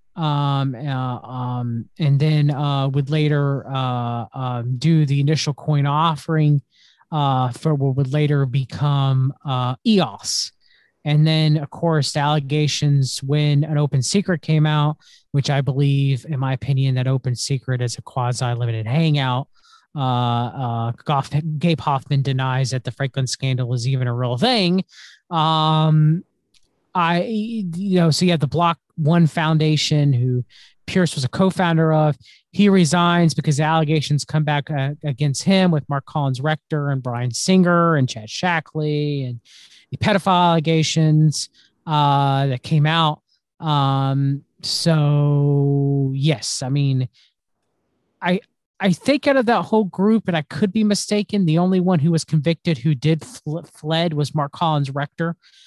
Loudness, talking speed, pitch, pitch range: -19 LUFS, 150 wpm, 150 Hz, 135-165 Hz